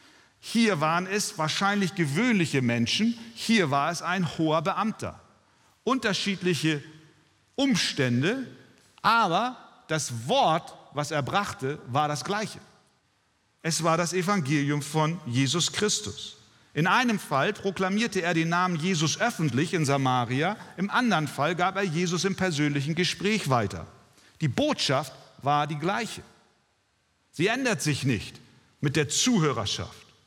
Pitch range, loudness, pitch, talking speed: 150-200 Hz, -26 LUFS, 170 Hz, 125 wpm